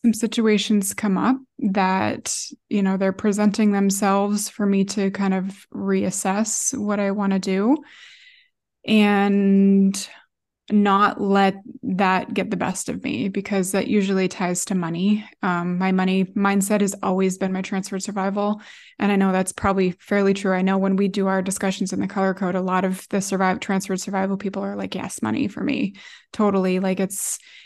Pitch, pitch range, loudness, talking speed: 195 Hz, 190-210 Hz, -21 LUFS, 175 wpm